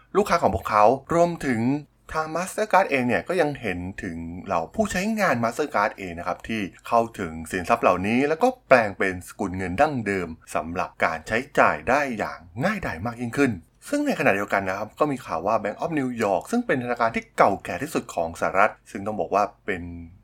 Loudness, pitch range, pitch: -24 LUFS, 100-155 Hz, 120 Hz